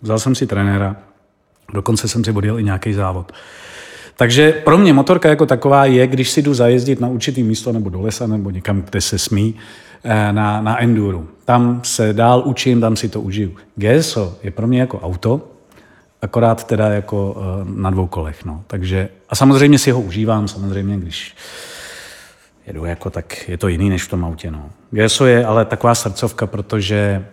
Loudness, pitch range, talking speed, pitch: -15 LUFS, 100-120 Hz, 180 wpm, 110 Hz